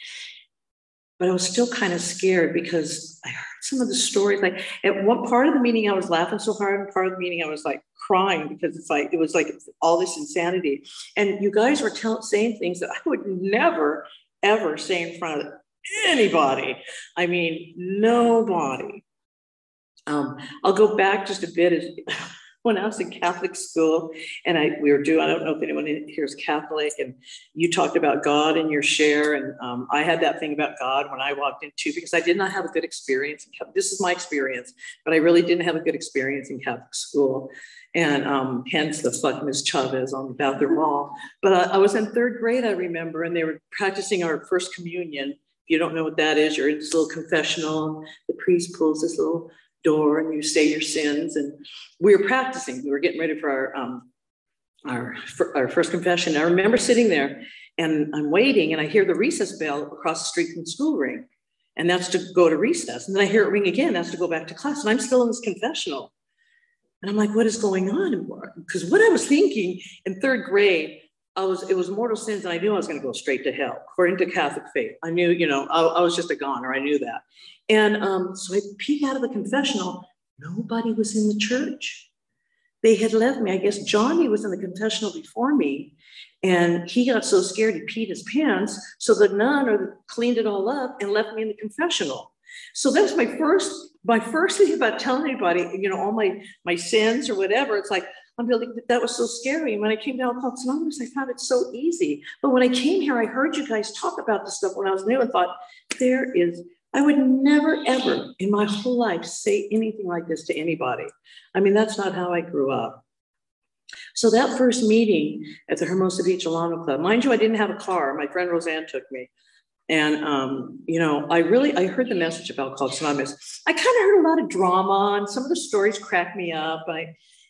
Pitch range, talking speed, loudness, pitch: 160-240 Hz, 225 wpm, -22 LUFS, 190 Hz